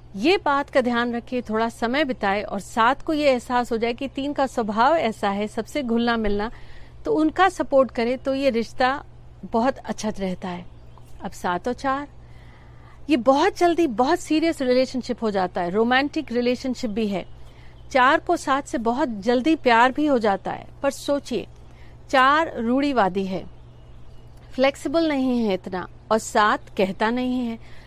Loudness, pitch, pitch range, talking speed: -22 LUFS, 245 Hz, 210-275 Hz, 165 wpm